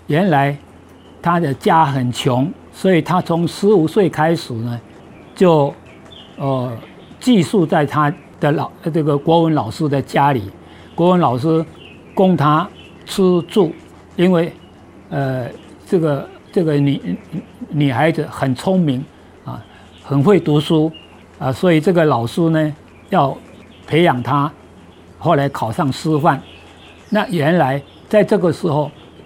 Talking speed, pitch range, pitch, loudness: 180 characters per minute, 130-170 Hz, 150 Hz, -16 LUFS